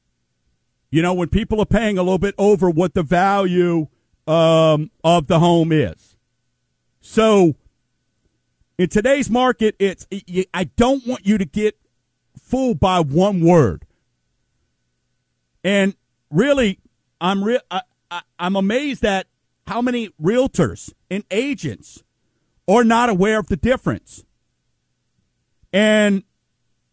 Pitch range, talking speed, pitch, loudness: 155-215 Hz, 115 wpm, 185 Hz, -18 LUFS